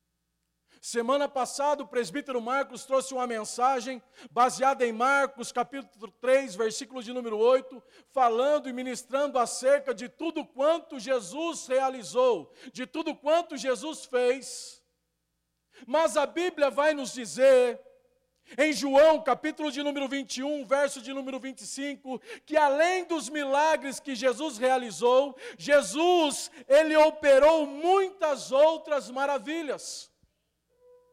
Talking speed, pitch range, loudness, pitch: 115 wpm, 250-300 Hz, -27 LUFS, 275 Hz